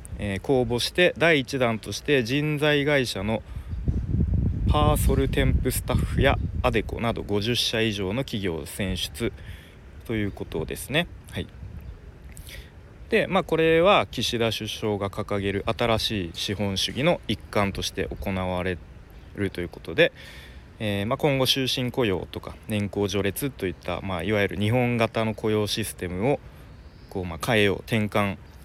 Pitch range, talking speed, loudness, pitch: 95-115 Hz, 285 characters per minute, -25 LUFS, 105 Hz